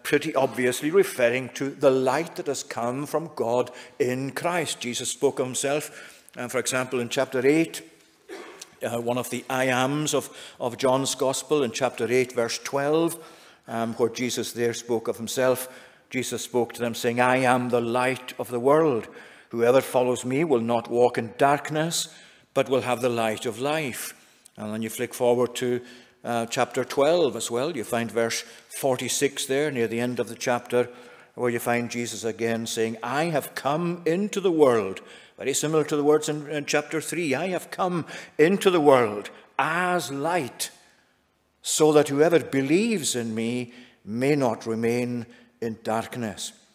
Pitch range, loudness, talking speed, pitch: 120-145 Hz, -25 LUFS, 170 wpm, 125 Hz